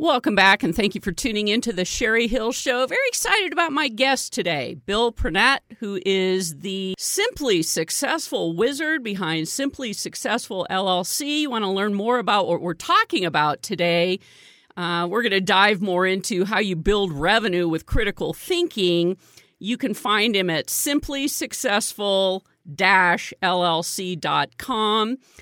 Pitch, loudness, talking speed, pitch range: 205 Hz, -21 LUFS, 145 wpm, 185-255 Hz